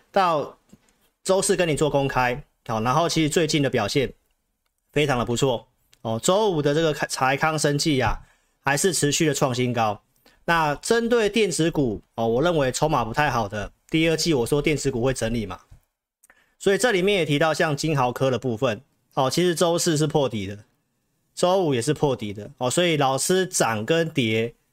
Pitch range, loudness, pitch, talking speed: 125-160 Hz, -22 LUFS, 145 Hz, 270 characters per minute